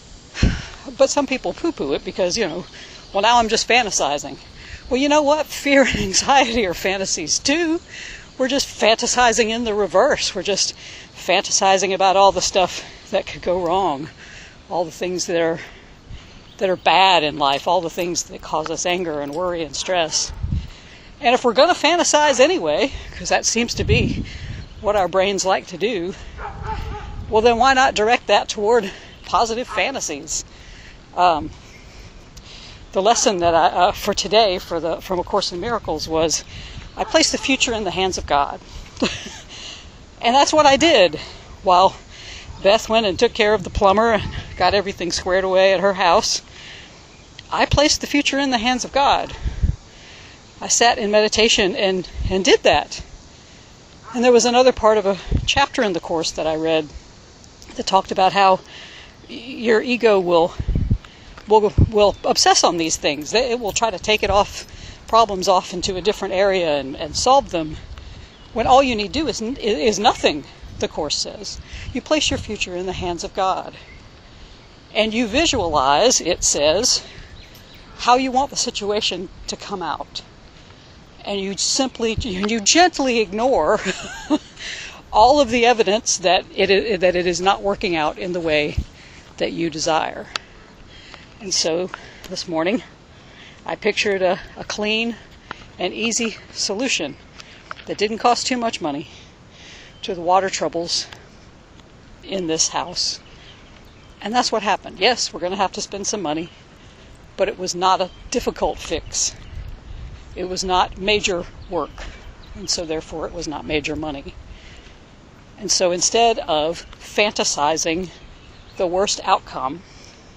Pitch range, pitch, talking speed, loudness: 175-235 Hz, 195 Hz, 160 wpm, -18 LUFS